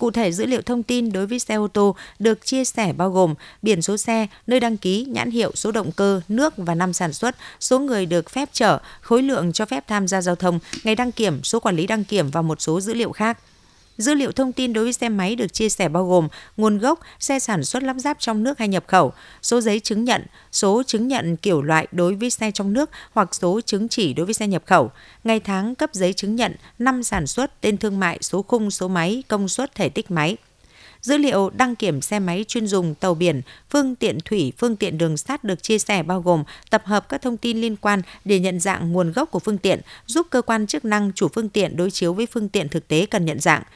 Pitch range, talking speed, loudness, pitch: 185-235 Hz, 250 wpm, -21 LUFS, 210 Hz